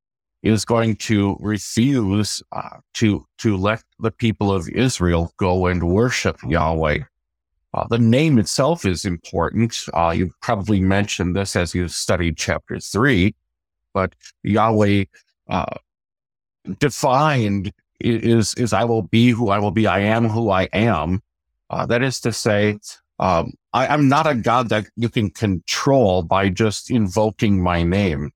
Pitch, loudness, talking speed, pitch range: 105 Hz, -19 LUFS, 150 wpm, 90-115 Hz